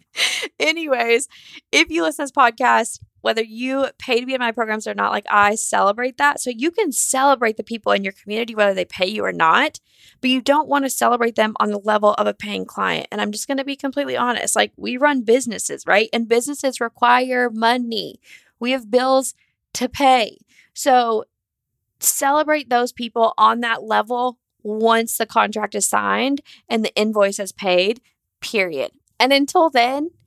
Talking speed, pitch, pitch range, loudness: 185 wpm, 240 Hz, 220-270 Hz, -19 LUFS